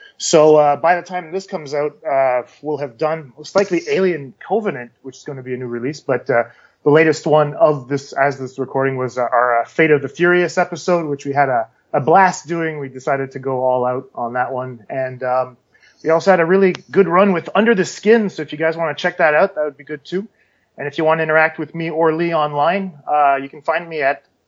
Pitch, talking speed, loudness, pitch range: 150 Hz, 250 wpm, -17 LUFS, 135-170 Hz